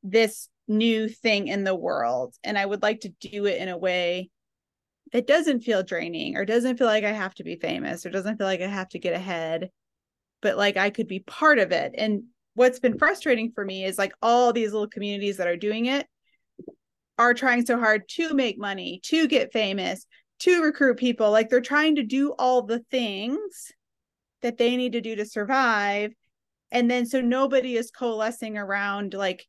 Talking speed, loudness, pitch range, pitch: 200 wpm, -24 LUFS, 200-250 Hz, 225 Hz